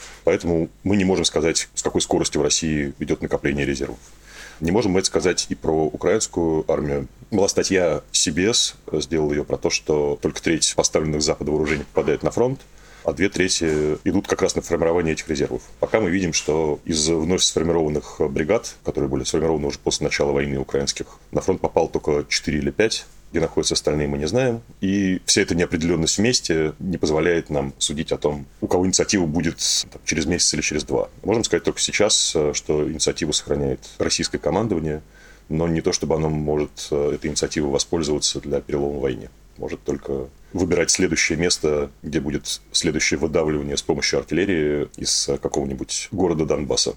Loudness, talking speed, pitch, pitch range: -21 LUFS, 170 wpm, 75 Hz, 75-85 Hz